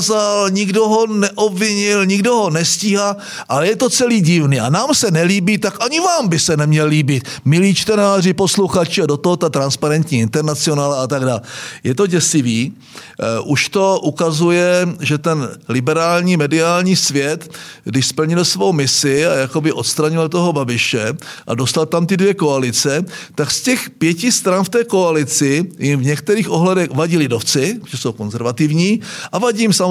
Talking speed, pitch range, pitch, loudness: 160 wpm, 145-195 Hz, 165 Hz, -15 LUFS